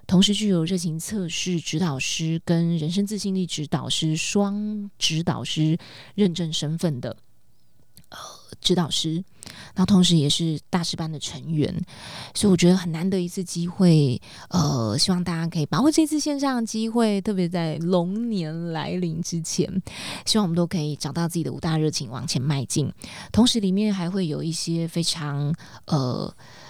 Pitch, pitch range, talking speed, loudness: 170 Hz, 155-190 Hz, 255 characters per minute, -24 LUFS